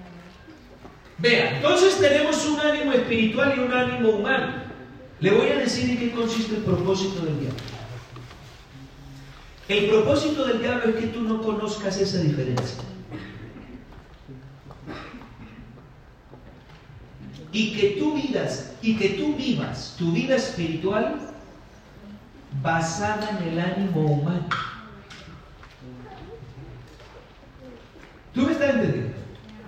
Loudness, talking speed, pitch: -23 LUFS, 105 wpm, 195 Hz